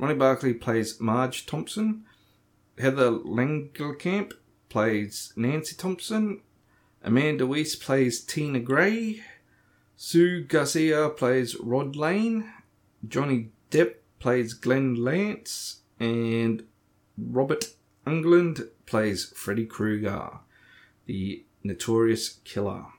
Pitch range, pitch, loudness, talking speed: 110-155 Hz, 125 Hz, -26 LUFS, 90 wpm